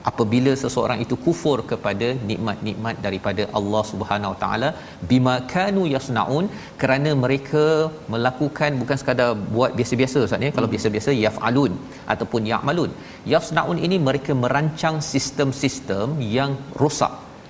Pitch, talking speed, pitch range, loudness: 125 Hz, 115 wpm, 110-145 Hz, -22 LUFS